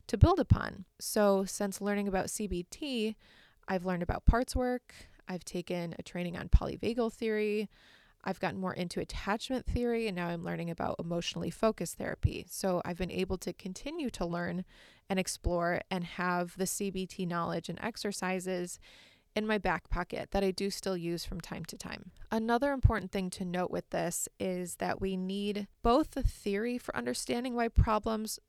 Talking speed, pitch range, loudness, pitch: 175 wpm, 180-215 Hz, -34 LUFS, 190 Hz